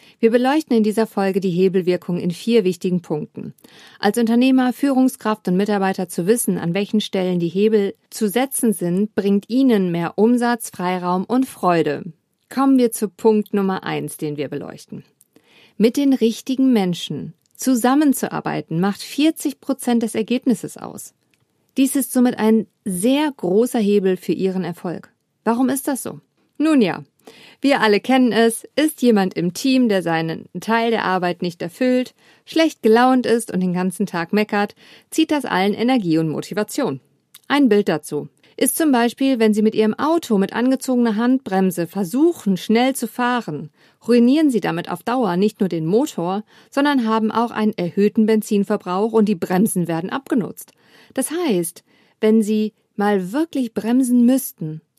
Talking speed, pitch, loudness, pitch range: 155 wpm, 215 Hz, -19 LUFS, 185-250 Hz